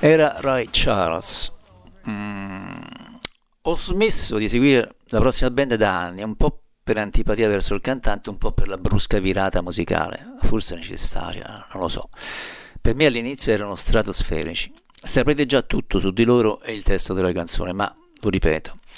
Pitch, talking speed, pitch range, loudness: 110 Hz, 160 wpm, 95-125 Hz, -21 LUFS